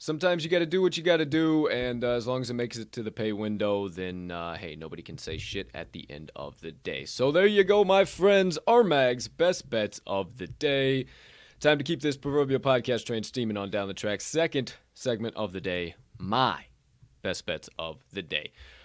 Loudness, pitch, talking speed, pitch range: -27 LUFS, 125 Hz, 225 wpm, 105-160 Hz